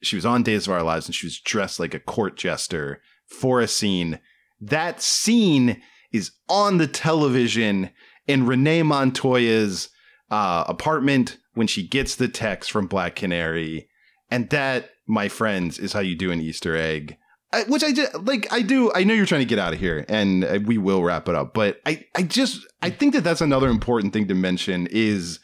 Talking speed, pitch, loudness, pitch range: 200 wpm, 115 Hz, -22 LUFS, 95-160 Hz